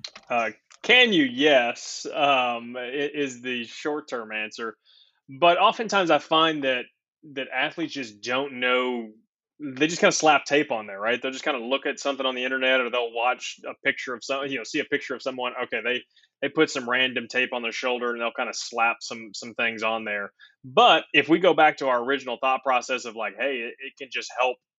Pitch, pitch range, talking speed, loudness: 130 Hz, 125-145 Hz, 220 wpm, -24 LUFS